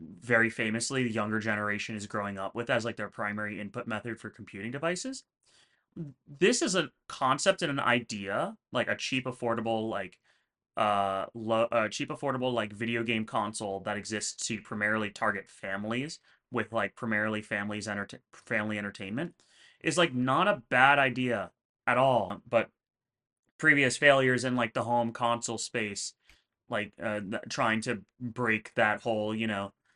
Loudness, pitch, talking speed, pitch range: -30 LUFS, 115 Hz, 155 wpm, 105-125 Hz